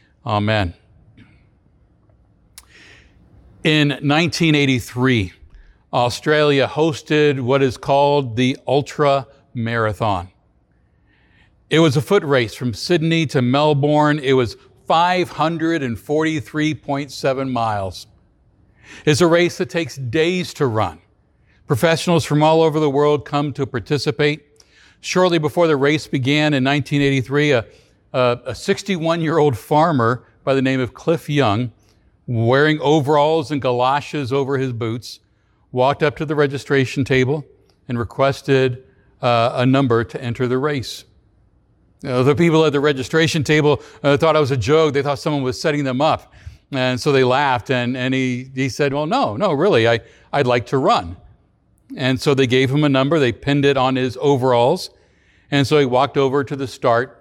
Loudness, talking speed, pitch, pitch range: -18 LUFS, 150 wpm, 140 Hz, 125-150 Hz